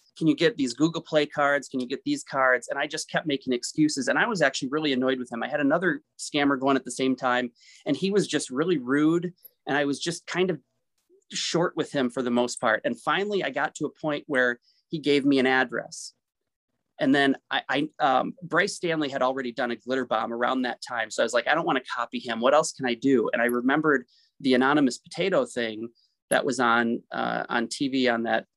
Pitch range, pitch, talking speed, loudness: 125-155 Hz, 140 Hz, 235 wpm, -25 LUFS